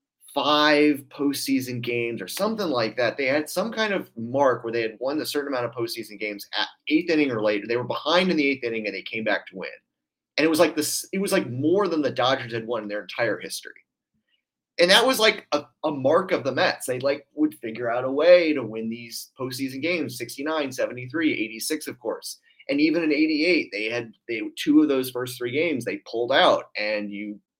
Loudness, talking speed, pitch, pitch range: -24 LUFS, 225 wpm, 140 Hz, 115-170 Hz